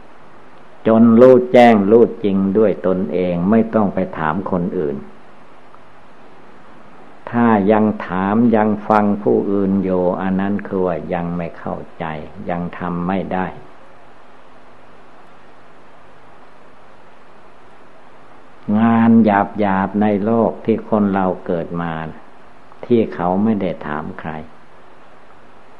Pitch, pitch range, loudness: 95 Hz, 90-110 Hz, -16 LUFS